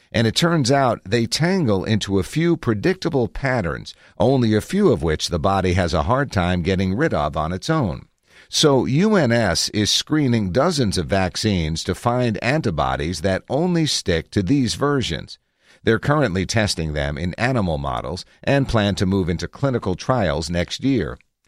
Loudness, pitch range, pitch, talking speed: -20 LUFS, 90-135 Hz, 105 Hz, 170 wpm